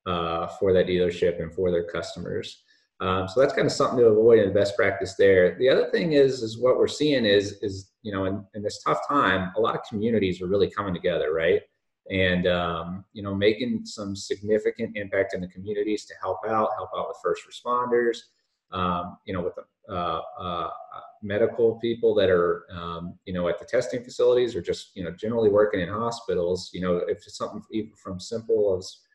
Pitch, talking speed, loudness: 115 Hz, 205 wpm, -25 LUFS